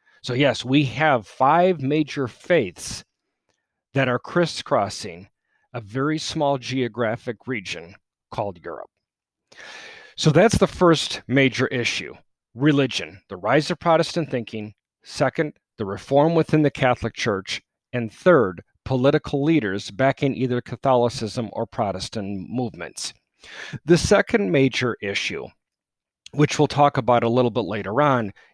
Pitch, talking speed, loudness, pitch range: 130 Hz, 125 wpm, -22 LUFS, 115-150 Hz